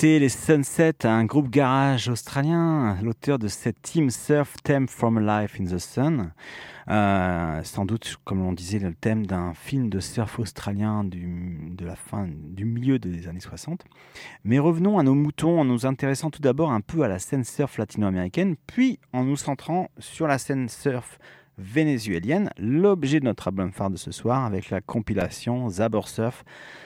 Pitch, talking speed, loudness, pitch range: 115 Hz, 175 wpm, -25 LUFS, 100-140 Hz